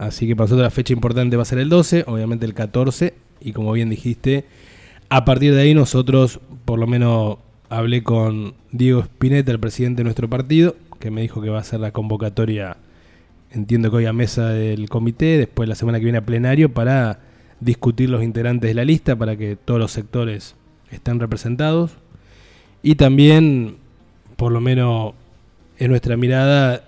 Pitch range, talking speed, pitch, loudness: 110-130 Hz, 180 wpm, 120 Hz, -18 LUFS